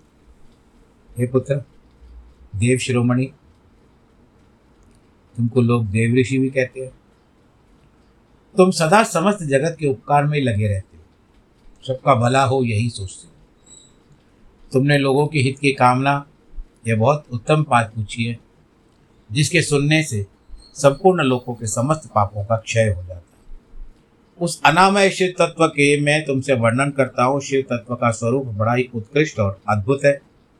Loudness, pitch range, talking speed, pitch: -18 LUFS, 110-140 Hz, 140 wpm, 125 Hz